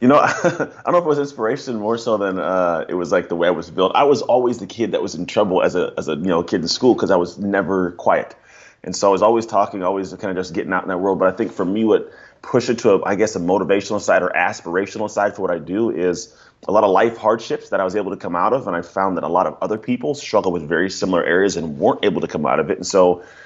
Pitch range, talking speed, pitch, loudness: 95-115 Hz, 305 wpm, 100 Hz, -19 LUFS